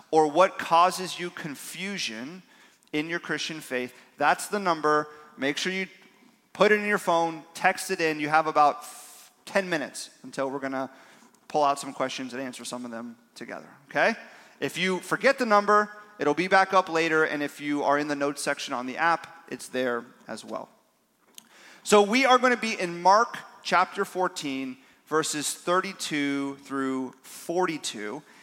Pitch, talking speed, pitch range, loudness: 160 Hz, 170 wpm, 140-185 Hz, -26 LUFS